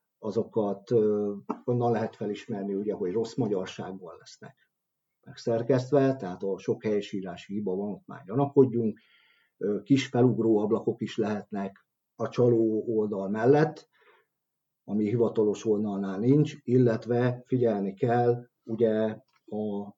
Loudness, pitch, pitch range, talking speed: -28 LUFS, 115 Hz, 105-120 Hz, 110 wpm